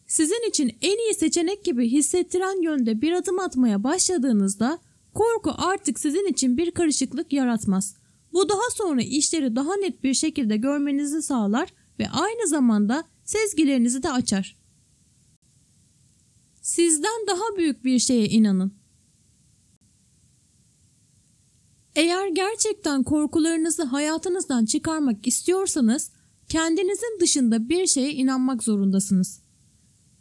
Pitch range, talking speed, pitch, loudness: 255-360 Hz, 105 wpm, 305 Hz, -23 LUFS